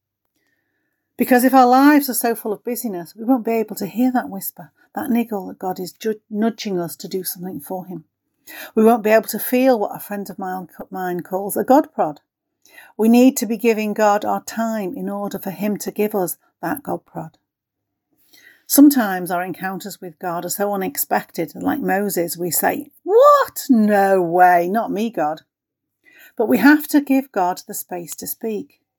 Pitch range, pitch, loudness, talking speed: 185-250 Hz, 210 Hz, -18 LUFS, 185 wpm